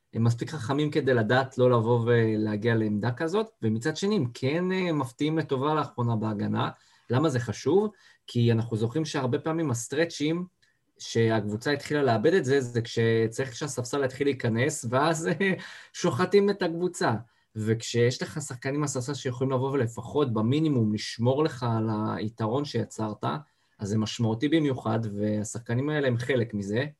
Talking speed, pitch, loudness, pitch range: 140 wpm, 130 Hz, -27 LUFS, 115-150 Hz